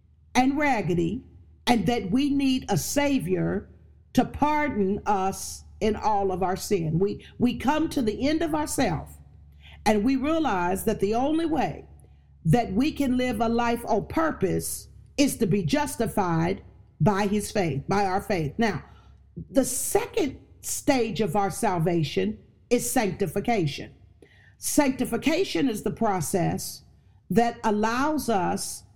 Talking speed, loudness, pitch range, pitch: 135 wpm, -26 LUFS, 190-270 Hz, 220 Hz